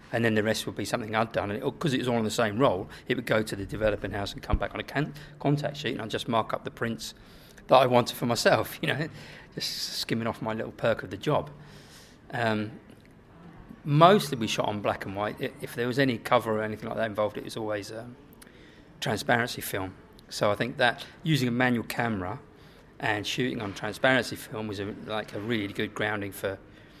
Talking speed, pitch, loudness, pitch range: 230 wpm, 115 Hz, -28 LUFS, 105-130 Hz